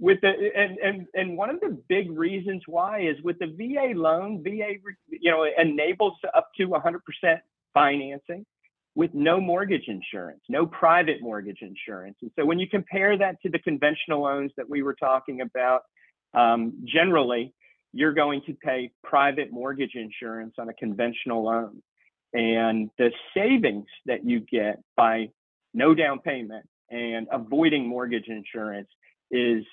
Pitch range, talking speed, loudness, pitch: 115-185 Hz, 150 wpm, -25 LUFS, 150 Hz